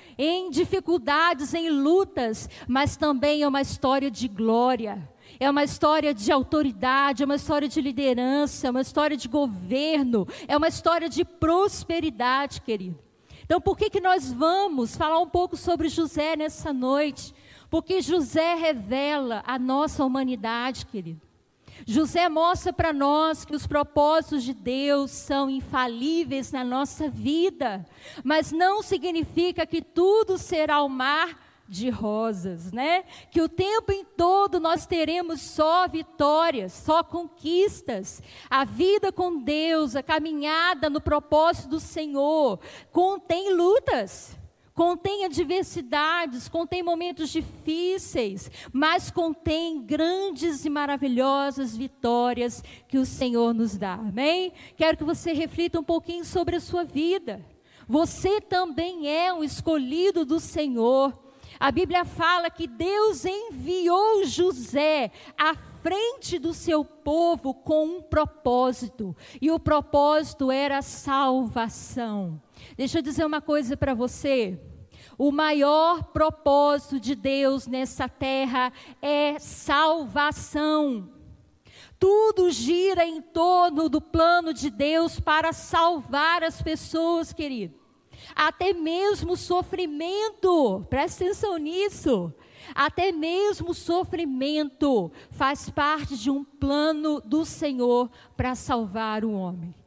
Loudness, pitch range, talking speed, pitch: -25 LUFS, 270-340 Hz, 125 wpm, 305 Hz